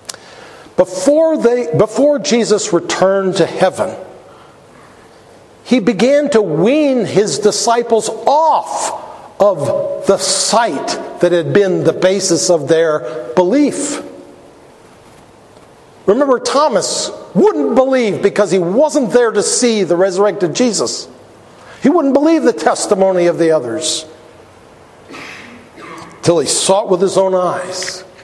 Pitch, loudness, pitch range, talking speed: 200 Hz, -13 LUFS, 180-250 Hz, 115 wpm